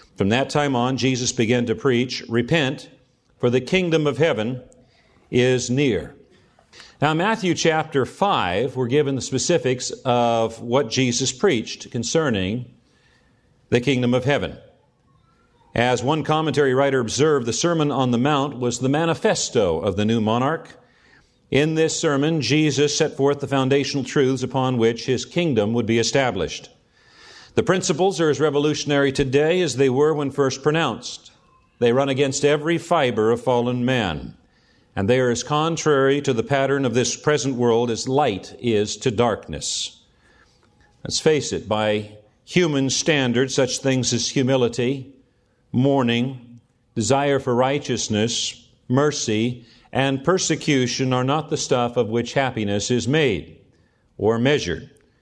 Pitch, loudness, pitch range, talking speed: 130 Hz, -21 LUFS, 120-145 Hz, 140 wpm